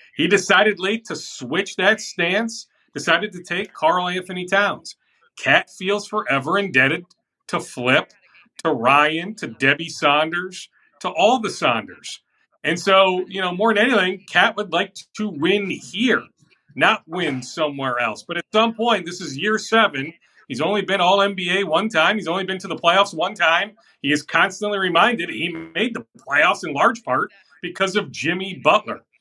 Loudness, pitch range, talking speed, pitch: -19 LUFS, 165-210 Hz, 170 wpm, 190 Hz